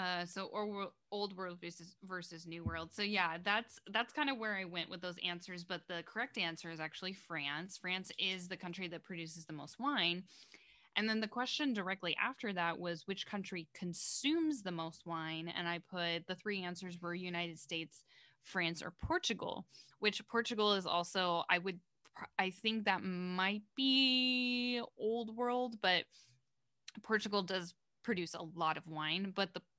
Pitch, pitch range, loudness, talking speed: 185 Hz, 170-210 Hz, -38 LUFS, 175 wpm